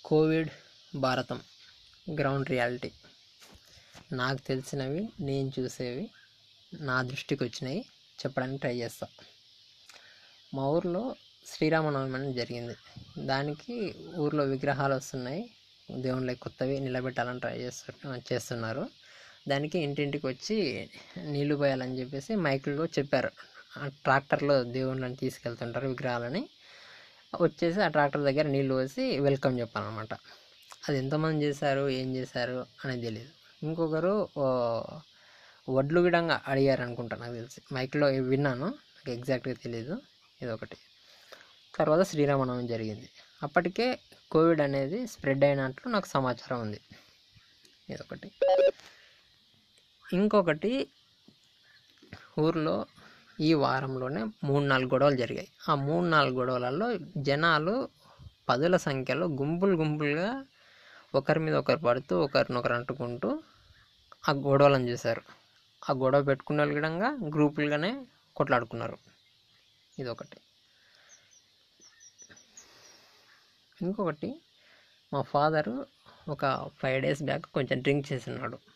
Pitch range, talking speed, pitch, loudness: 130-160 Hz, 95 wpm, 140 Hz, -30 LUFS